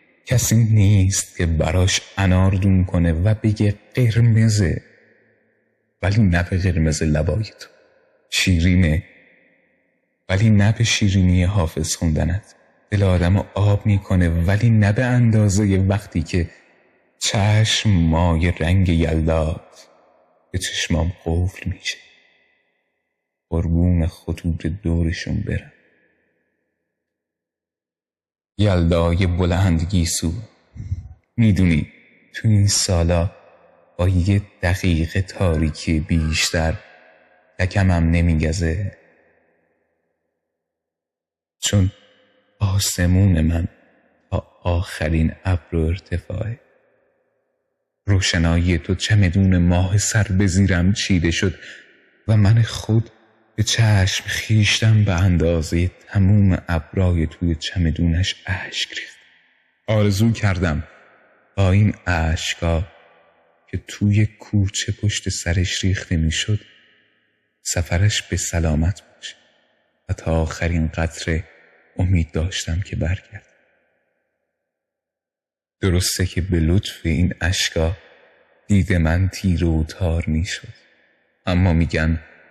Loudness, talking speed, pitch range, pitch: -19 LUFS, 90 wpm, 85-100 Hz, 90 Hz